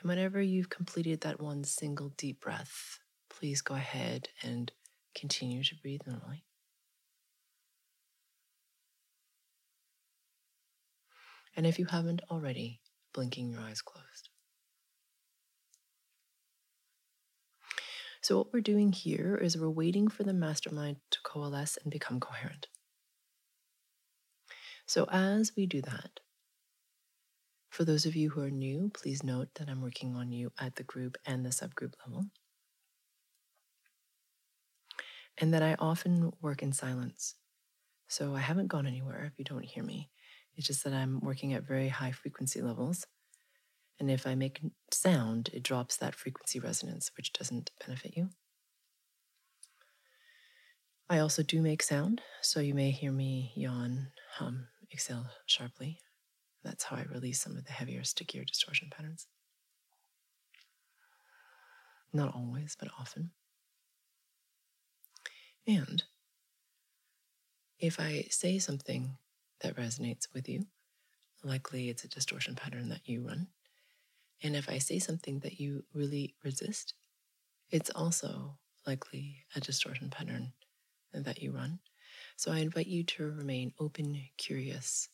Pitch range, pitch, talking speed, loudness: 135-165 Hz, 140 Hz, 130 wpm, -36 LUFS